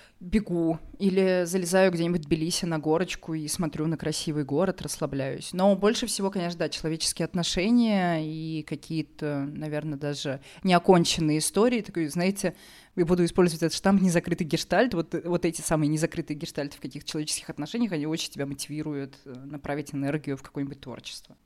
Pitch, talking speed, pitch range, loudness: 165 Hz, 155 wpm, 150-180 Hz, -27 LUFS